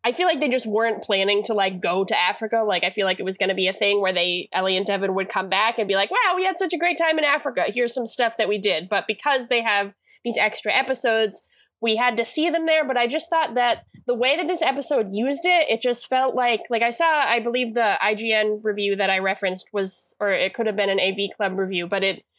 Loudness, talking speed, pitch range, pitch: -21 LUFS, 270 wpm, 200-255 Hz, 225 Hz